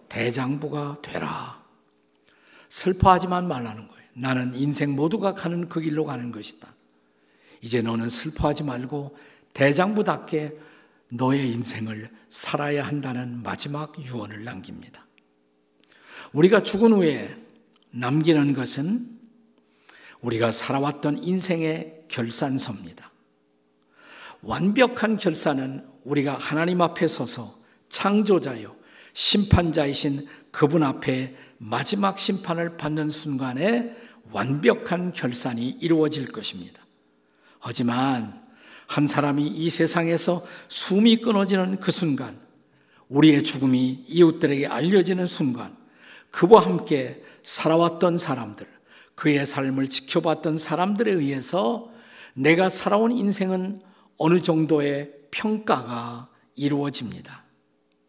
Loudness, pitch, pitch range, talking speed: -23 LUFS, 145 Hz, 125-175 Hz, 245 characters per minute